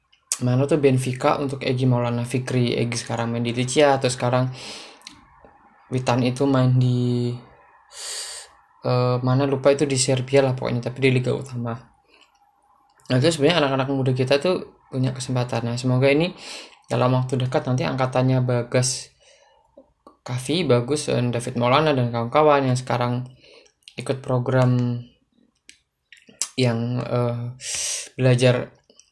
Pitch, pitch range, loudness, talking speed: 125 Hz, 120-135 Hz, -22 LUFS, 130 wpm